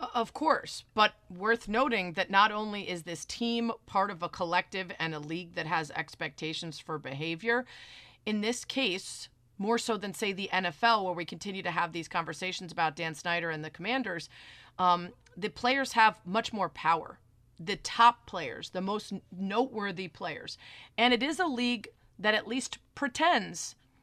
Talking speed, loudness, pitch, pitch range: 170 wpm, -31 LUFS, 195 Hz, 170-230 Hz